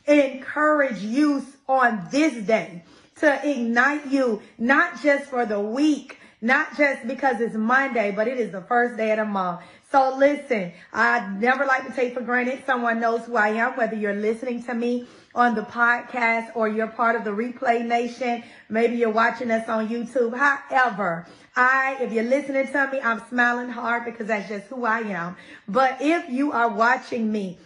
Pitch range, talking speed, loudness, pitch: 225-265 Hz, 180 wpm, -22 LUFS, 240 Hz